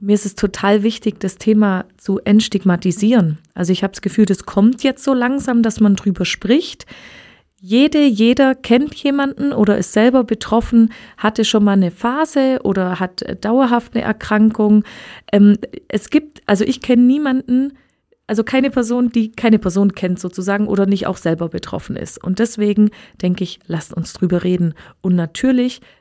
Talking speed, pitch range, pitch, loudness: 165 wpm, 195-245 Hz, 215 Hz, -16 LUFS